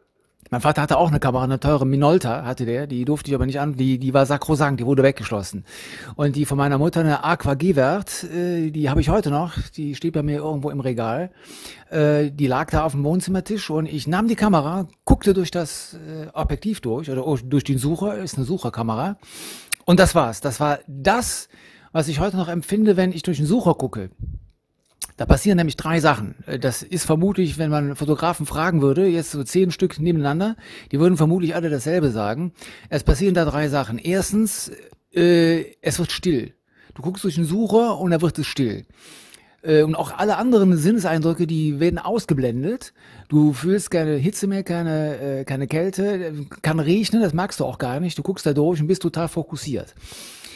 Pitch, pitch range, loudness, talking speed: 155 Hz, 140-180 Hz, -21 LUFS, 190 wpm